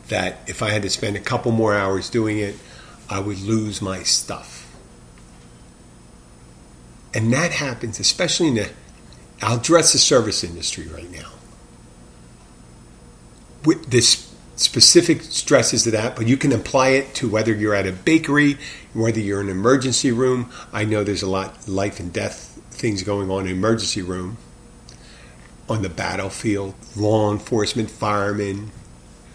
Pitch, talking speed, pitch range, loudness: 105 Hz, 150 wpm, 90-115 Hz, -19 LUFS